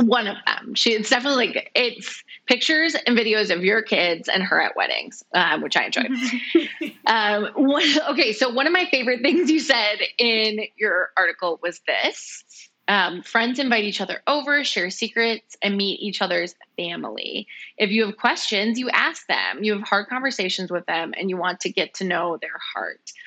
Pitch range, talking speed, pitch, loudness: 200-270 Hz, 190 wpm, 230 Hz, -21 LUFS